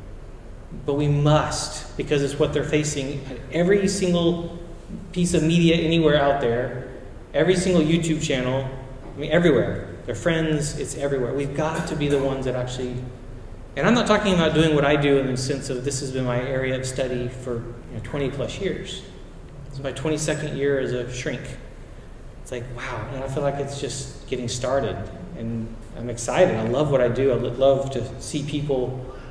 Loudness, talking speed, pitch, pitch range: -23 LUFS, 190 wpm, 140 Hz, 125-150 Hz